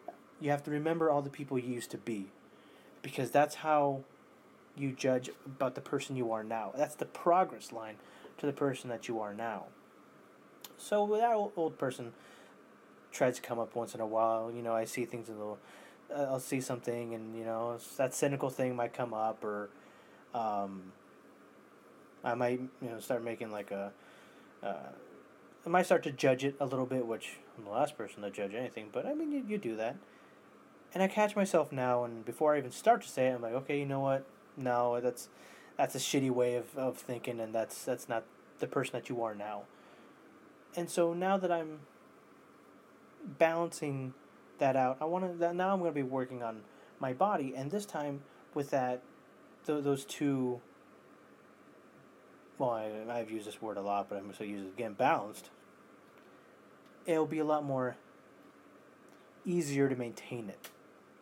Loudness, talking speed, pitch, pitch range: -35 LUFS, 185 wpm, 125 Hz, 115-145 Hz